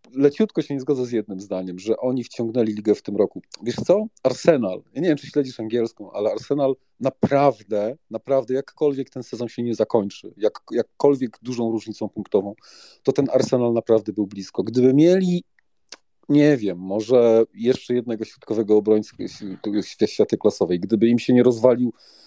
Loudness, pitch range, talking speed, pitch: -21 LUFS, 110-135 Hz, 160 wpm, 120 Hz